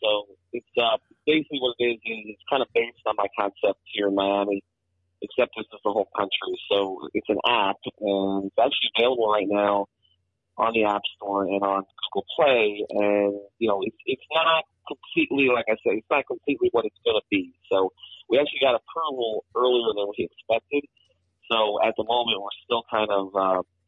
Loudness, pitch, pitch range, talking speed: -24 LUFS, 110 Hz, 100-155 Hz, 195 wpm